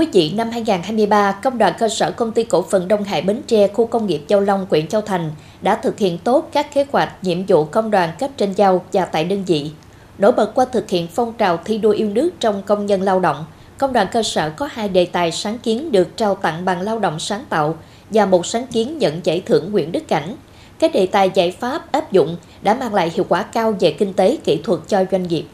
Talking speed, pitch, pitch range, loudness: 250 wpm, 205 Hz, 185-225 Hz, -18 LUFS